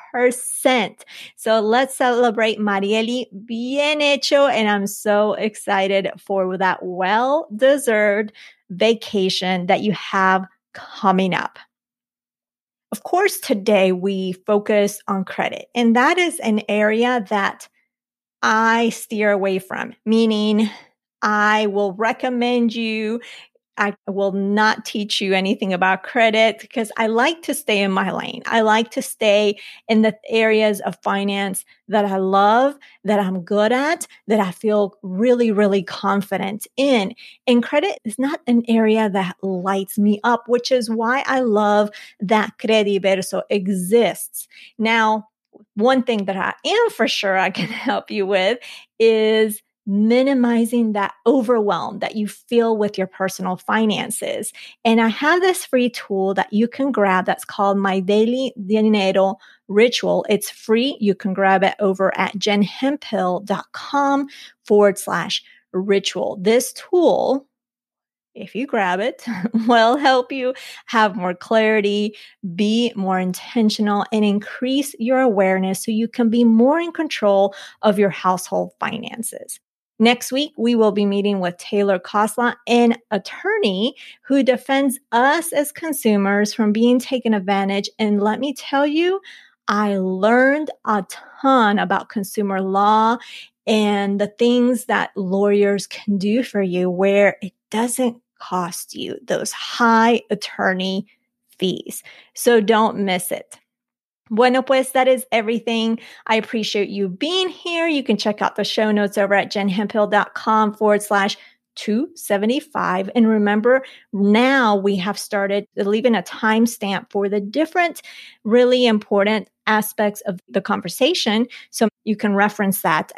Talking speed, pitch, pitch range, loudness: 135 wpm, 215 Hz, 200-240 Hz, -19 LUFS